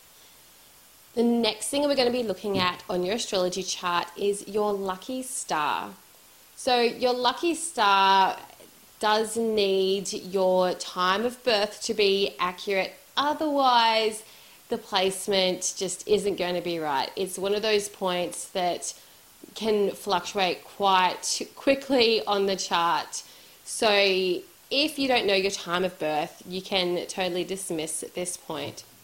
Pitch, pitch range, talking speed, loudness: 195 Hz, 180-220 Hz, 140 wpm, -25 LUFS